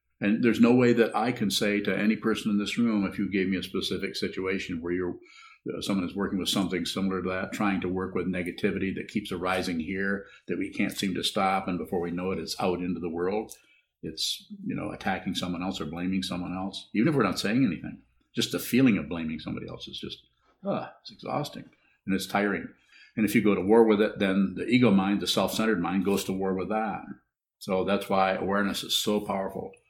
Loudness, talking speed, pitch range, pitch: -28 LUFS, 235 wpm, 95-105 Hz, 95 Hz